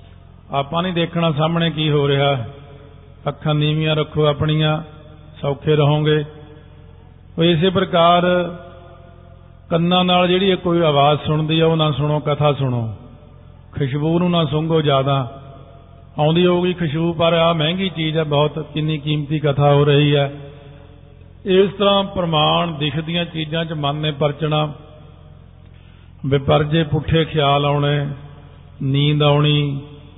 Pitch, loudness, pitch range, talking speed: 150 Hz, -17 LUFS, 140-165 Hz, 120 wpm